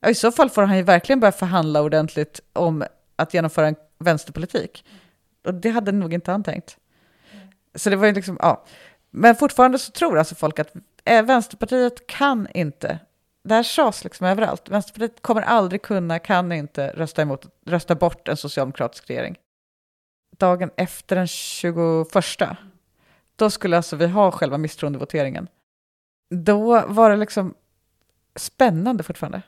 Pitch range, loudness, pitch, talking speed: 160-215 Hz, -20 LUFS, 180 Hz, 150 wpm